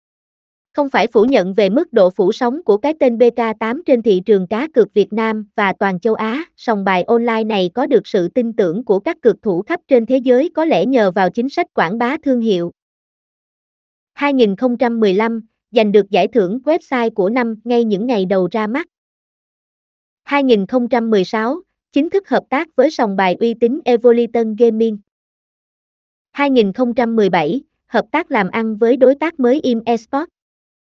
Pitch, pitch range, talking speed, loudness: 240 Hz, 220-275 Hz, 170 wpm, -16 LUFS